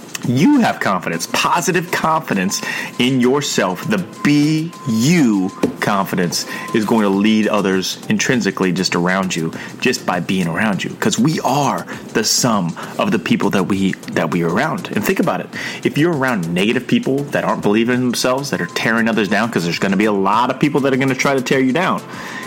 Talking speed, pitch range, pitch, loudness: 205 wpm, 100-140 Hz, 120 Hz, -17 LUFS